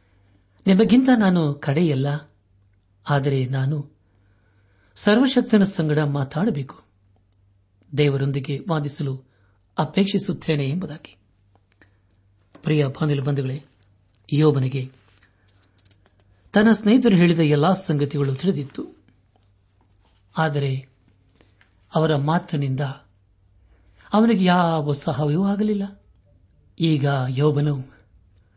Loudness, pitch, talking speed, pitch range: -21 LUFS, 135 Hz, 65 wpm, 100-155 Hz